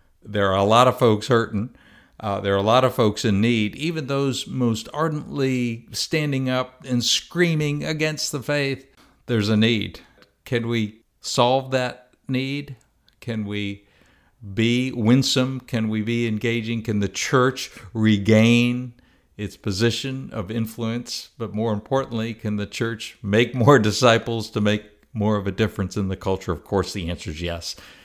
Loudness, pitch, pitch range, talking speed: -22 LUFS, 115 Hz, 105-130 Hz, 160 wpm